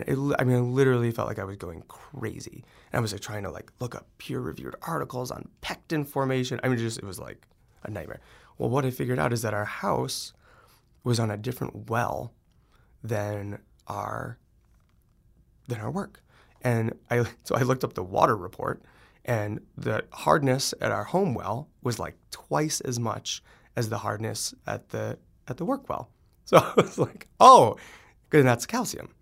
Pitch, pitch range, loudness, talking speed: 120 Hz, 105-125 Hz, -27 LUFS, 185 wpm